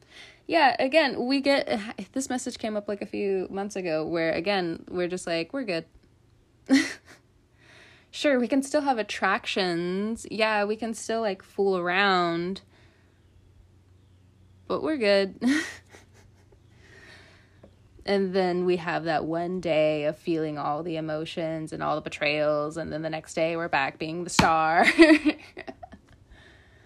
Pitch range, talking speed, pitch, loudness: 140-205 Hz, 140 wpm, 170 Hz, -26 LUFS